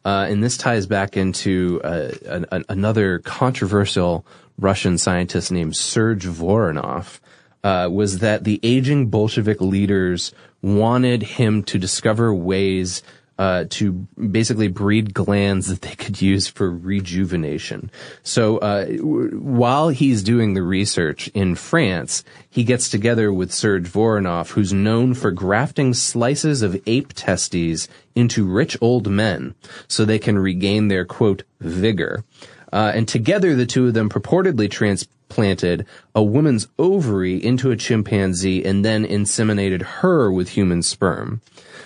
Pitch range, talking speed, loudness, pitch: 95-115 Hz, 140 wpm, -19 LUFS, 105 Hz